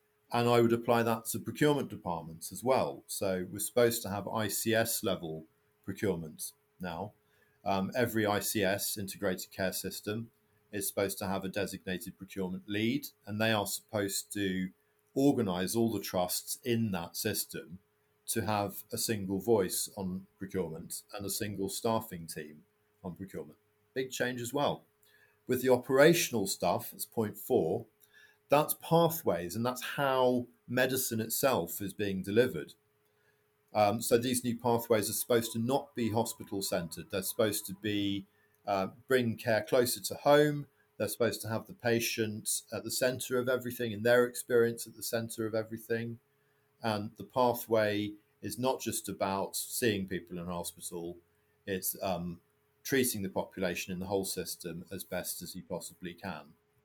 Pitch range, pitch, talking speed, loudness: 95-120 Hz, 110 Hz, 155 wpm, -32 LUFS